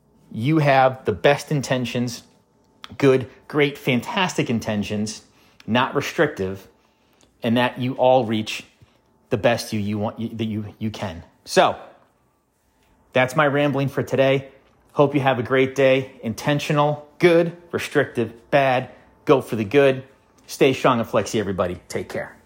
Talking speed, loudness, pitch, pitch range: 140 wpm, -21 LUFS, 130 Hz, 110-140 Hz